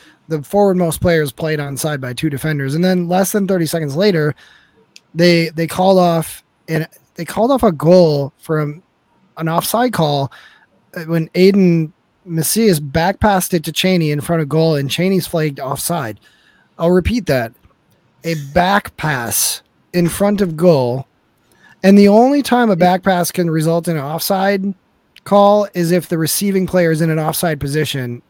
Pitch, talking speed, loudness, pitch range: 170 Hz, 170 wpm, -15 LUFS, 155-190 Hz